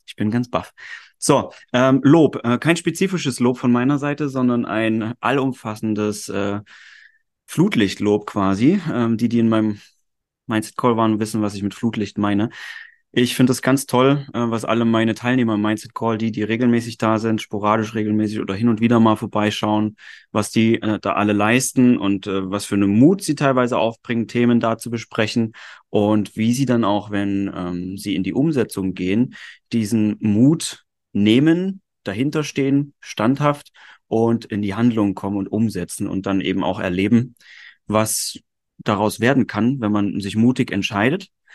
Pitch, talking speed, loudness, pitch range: 110 Hz, 170 wpm, -19 LUFS, 105-125 Hz